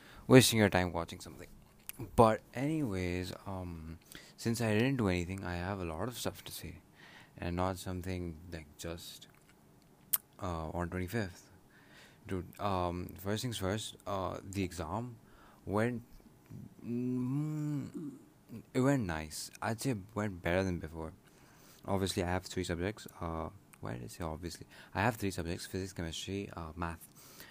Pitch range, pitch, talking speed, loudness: 85-110 Hz, 95 Hz, 150 wpm, -35 LUFS